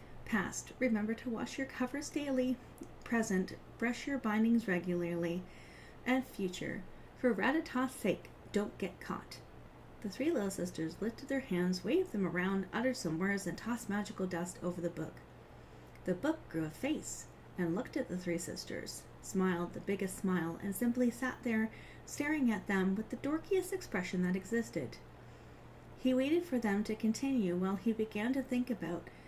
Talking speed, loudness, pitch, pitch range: 165 wpm, -37 LUFS, 215 Hz, 185-255 Hz